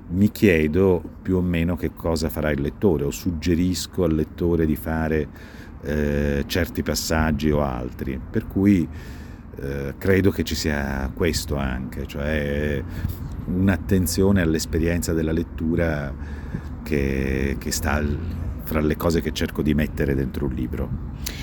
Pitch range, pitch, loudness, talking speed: 75-85 Hz, 80 Hz, -23 LUFS, 135 wpm